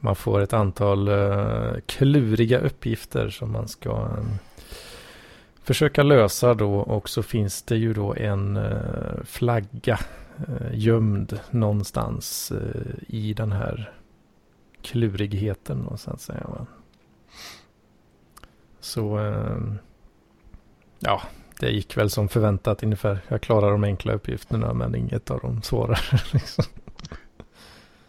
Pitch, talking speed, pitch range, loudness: 105 Hz, 110 wpm, 100-115 Hz, -24 LUFS